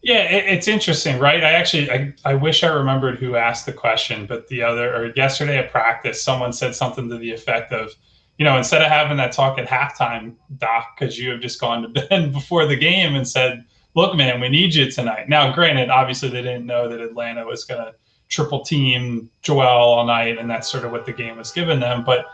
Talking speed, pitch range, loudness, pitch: 225 wpm, 120-145 Hz, -18 LUFS, 130 Hz